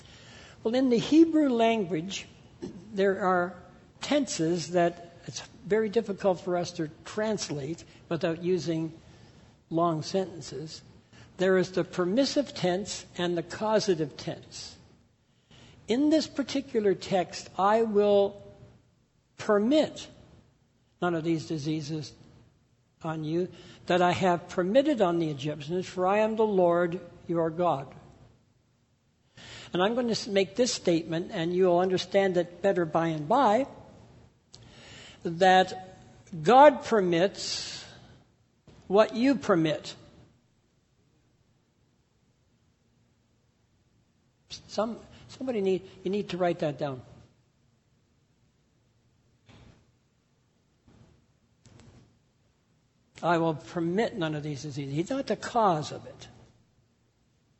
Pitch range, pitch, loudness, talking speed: 150-195 Hz, 175 Hz, -27 LUFS, 105 wpm